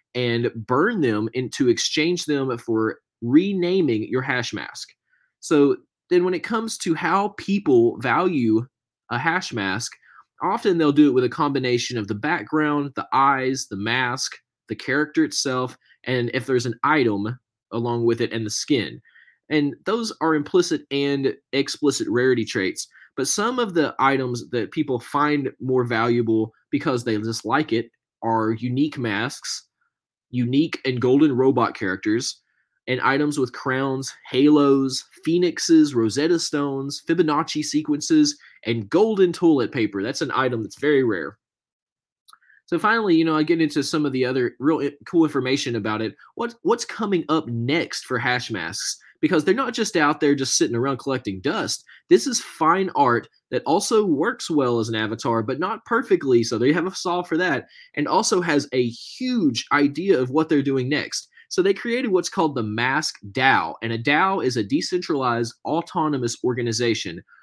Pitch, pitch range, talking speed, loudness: 140 Hz, 120-180 Hz, 165 wpm, -22 LUFS